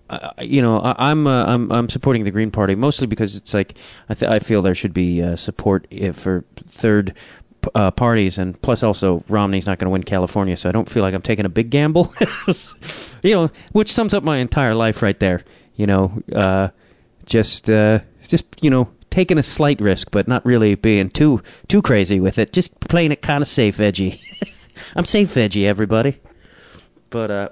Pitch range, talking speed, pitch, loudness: 100-135 Hz, 205 wpm, 110 Hz, -18 LUFS